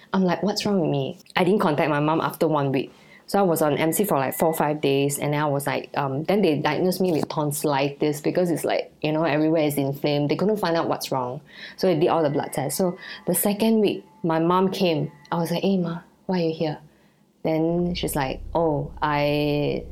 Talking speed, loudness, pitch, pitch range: 240 wpm, -23 LUFS, 160 Hz, 150-180 Hz